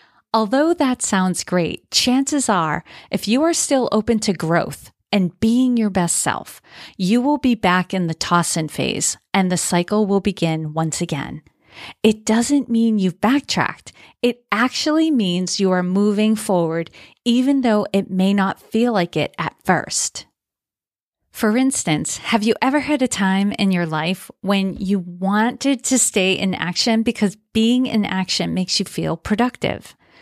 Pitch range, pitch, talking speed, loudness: 185-240 Hz, 210 Hz, 165 wpm, -19 LUFS